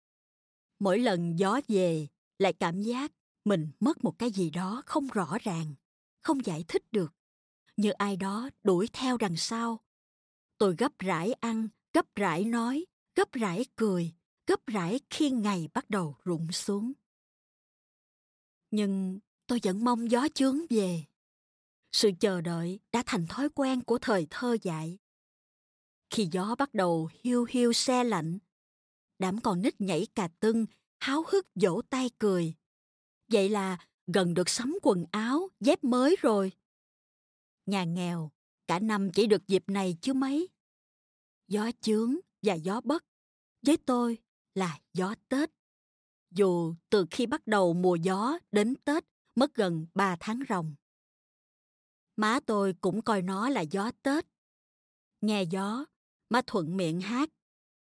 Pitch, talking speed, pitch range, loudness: 210 Hz, 145 wpm, 185-245 Hz, -30 LUFS